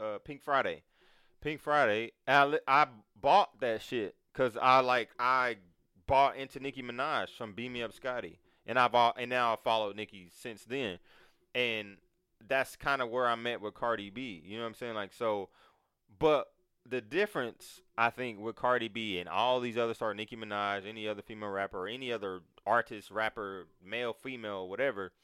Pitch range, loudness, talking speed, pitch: 105-130 Hz, -32 LUFS, 185 wpm, 120 Hz